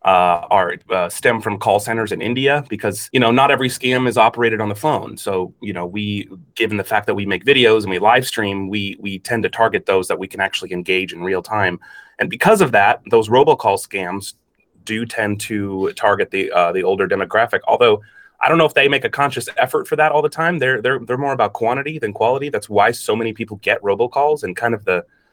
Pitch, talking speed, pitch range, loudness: 115 Hz, 235 wpm, 100-140 Hz, -17 LUFS